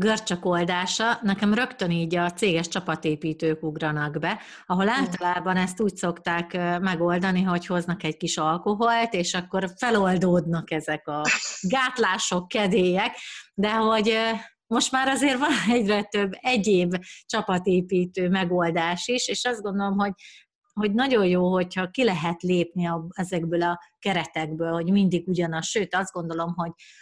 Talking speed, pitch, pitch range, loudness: 140 wpm, 185 Hz, 175-210 Hz, -24 LUFS